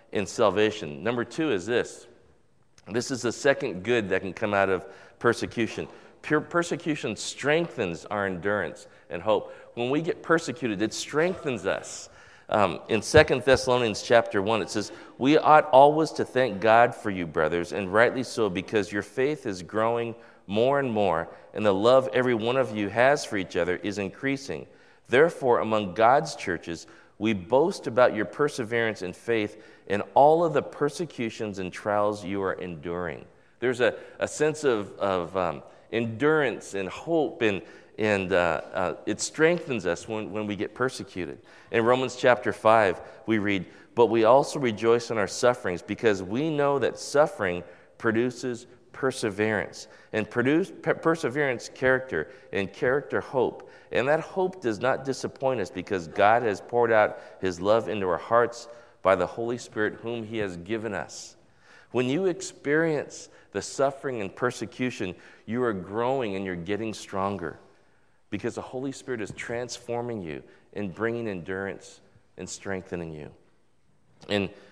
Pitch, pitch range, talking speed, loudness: 115 Hz, 100-130 Hz, 160 wpm, -26 LUFS